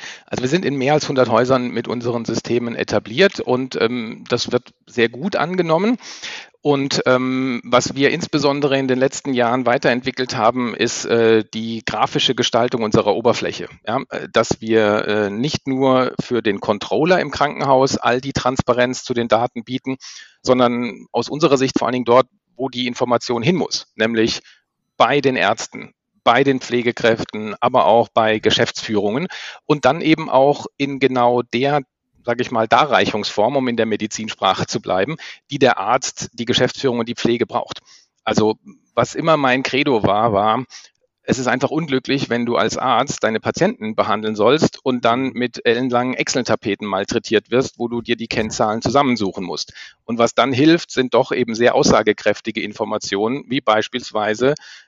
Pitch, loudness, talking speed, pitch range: 125 Hz, -18 LUFS, 165 wpm, 115-135 Hz